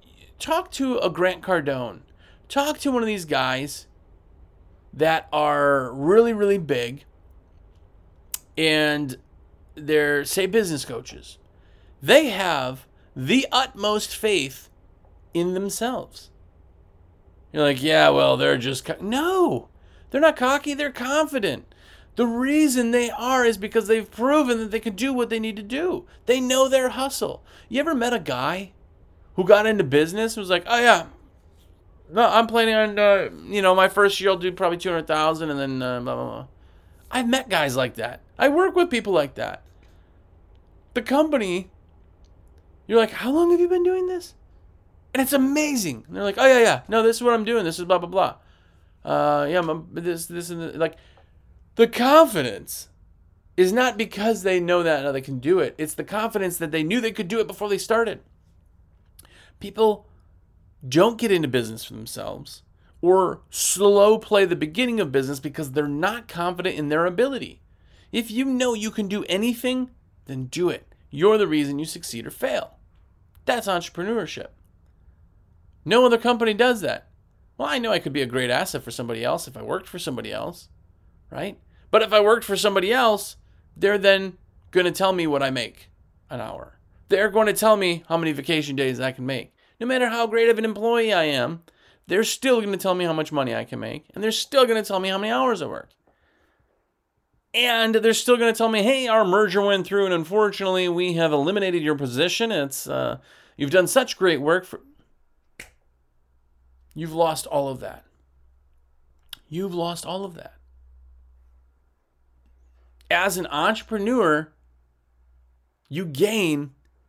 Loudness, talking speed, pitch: -22 LUFS, 175 wpm, 175 Hz